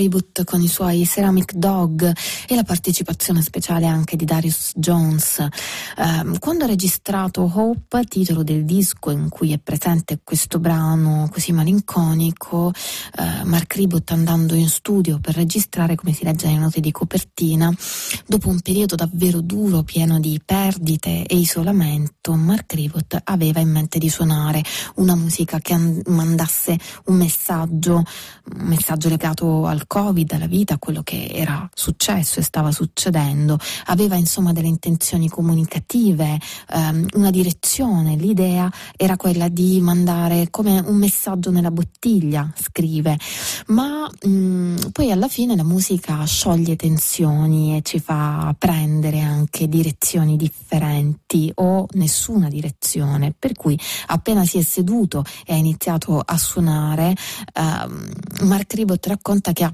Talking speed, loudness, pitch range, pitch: 140 wpm, -18 LUFS, 160-185 Hz, 170 Hz